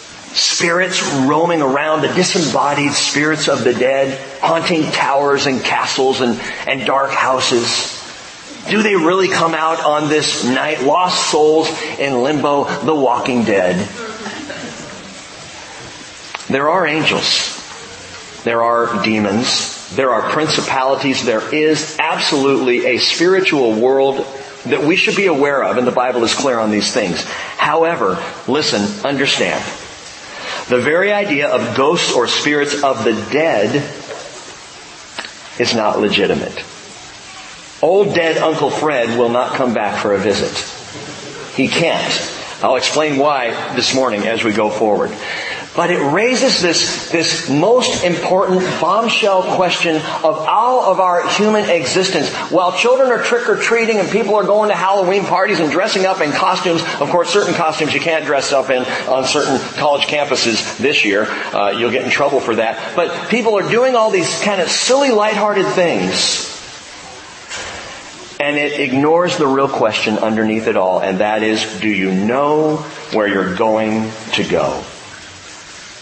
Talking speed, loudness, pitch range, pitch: 145 wpm, -15 LUFS, 125-180 Hz, 150 Hz